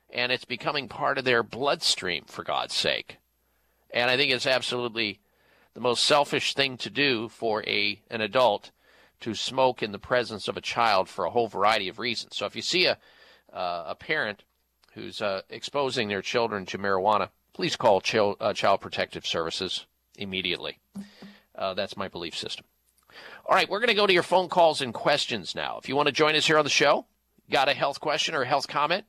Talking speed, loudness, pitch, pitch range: 200 wpm, -26 LUFS, 125 Hz, 100-150 Hz